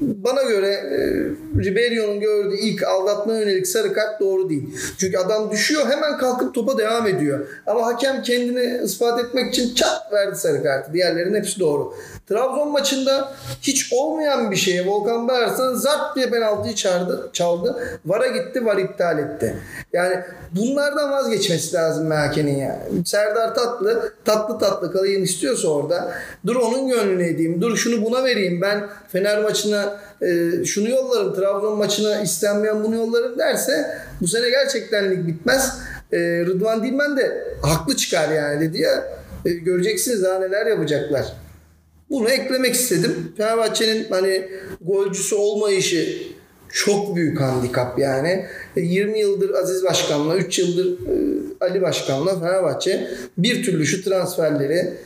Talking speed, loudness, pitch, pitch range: 140 wpm, -20 LUFS, 210 Hz, 185-250 Hz